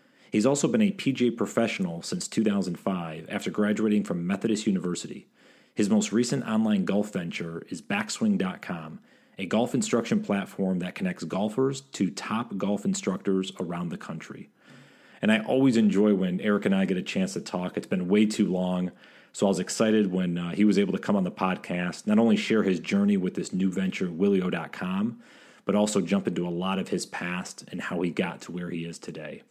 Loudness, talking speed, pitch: -27 LUFS, 195 wpm, 105 Hz